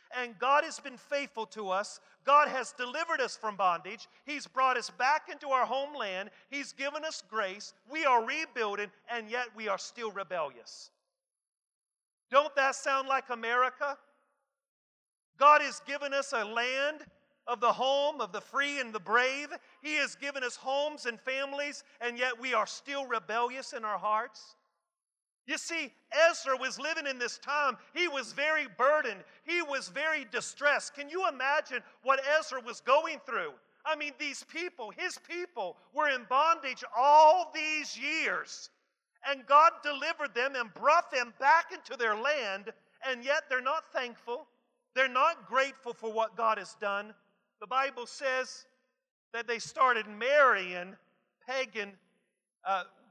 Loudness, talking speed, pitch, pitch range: -31 LUFS, 155 wpm, 265 Hz, 235-295 Hz